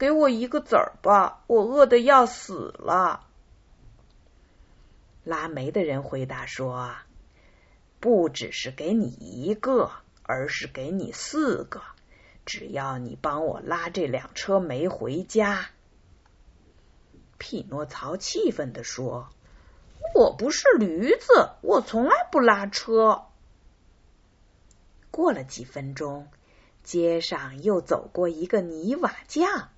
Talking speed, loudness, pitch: 155 characters per minute, -24 LUFS, 195 Hz